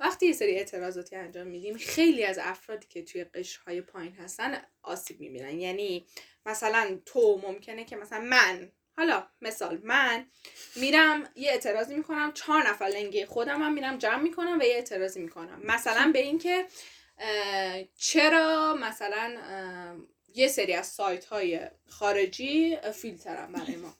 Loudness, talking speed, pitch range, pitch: -27 LUFS, 145 wpm, 190-300 Hz, 220 Hz